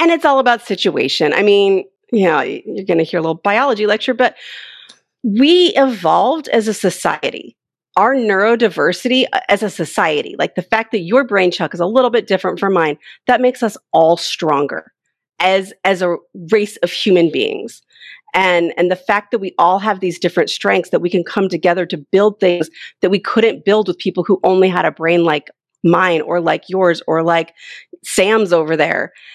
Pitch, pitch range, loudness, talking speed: 195 Hz, 175-230 Hz, -15 LUFS, 190 wpm